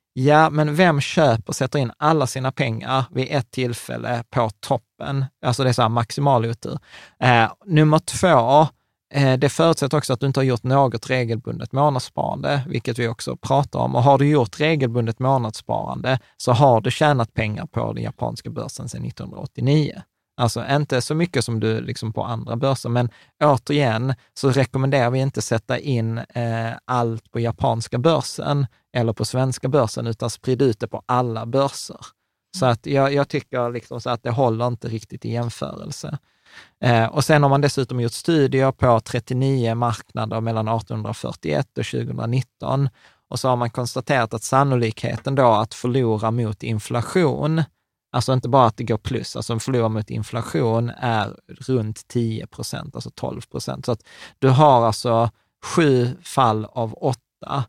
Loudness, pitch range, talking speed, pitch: -21 LUFS, 115-140 Hz, 165 wpm, 125 Hz